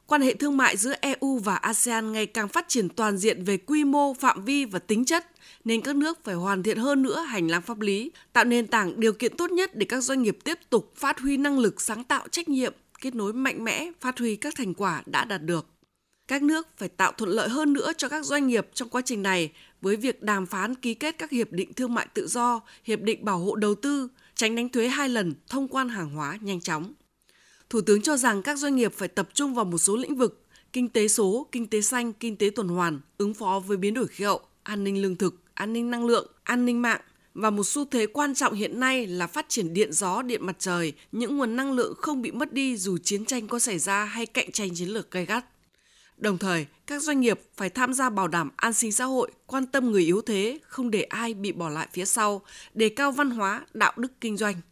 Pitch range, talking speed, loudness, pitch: 200-265 Hz, 250 wpm, -26 LUFS, 230 Hz